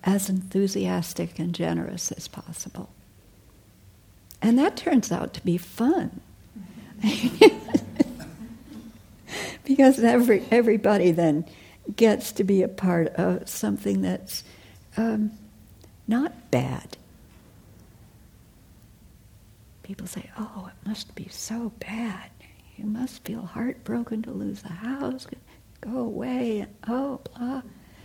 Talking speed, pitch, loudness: 105 wpm, 195 Hz, -25 LUFS